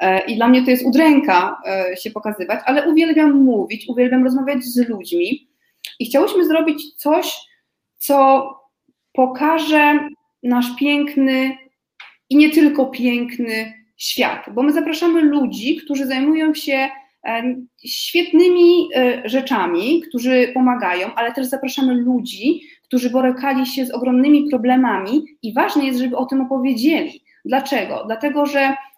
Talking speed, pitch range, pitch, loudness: 120 wpm, 250-300 Hz, 270 Hz, -17 LUFS